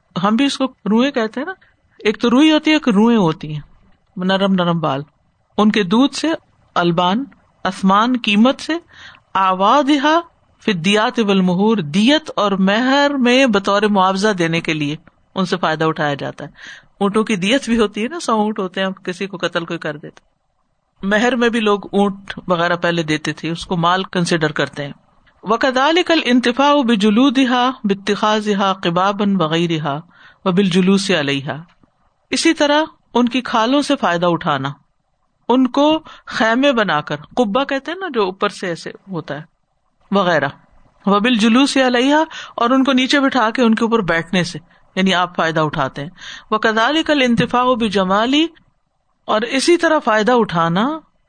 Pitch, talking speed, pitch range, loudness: 210 Hz, 165 wpm, 175-250 Hz, -16 LUFS